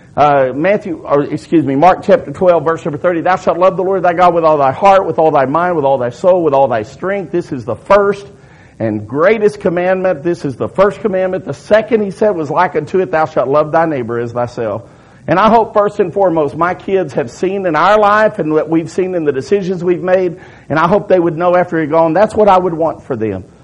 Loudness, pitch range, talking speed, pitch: -13 LUFS, 150-190 Hz, 250 wpm, 175 Hz